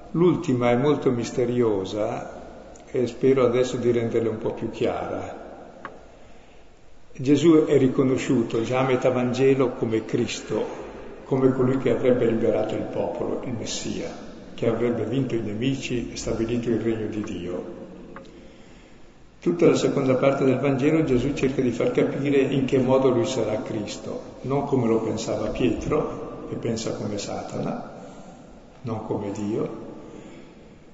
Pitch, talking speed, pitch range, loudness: 125 Hz, 140 wpm, 115-135 Hz, -24 LUFS